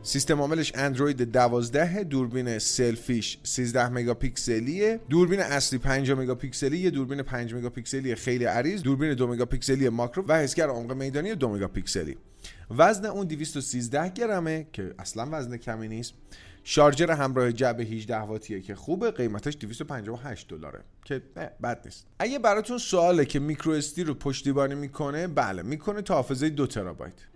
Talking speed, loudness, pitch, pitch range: 145 wpm, -27 LUFS, 135 Hz, 120-155 Hz